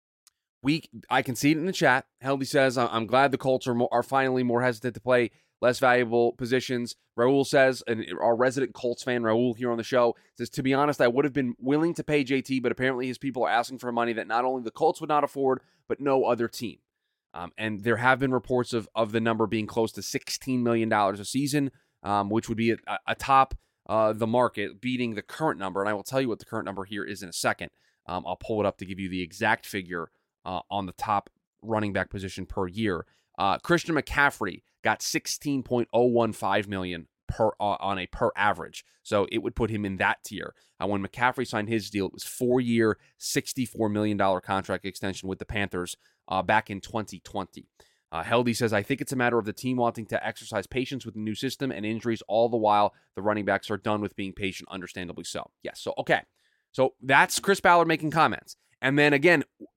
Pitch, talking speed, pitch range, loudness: 115 Hz, 220 wpm, 105-130 Hz, -27 LUFS